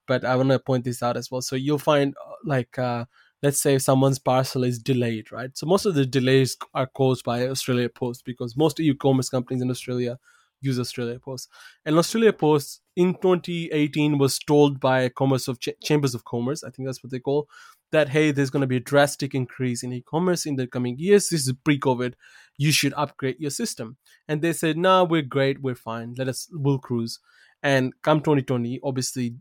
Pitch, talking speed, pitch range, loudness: 135 Hz, 210 wpm, 125-150 Hz, -23 LUFS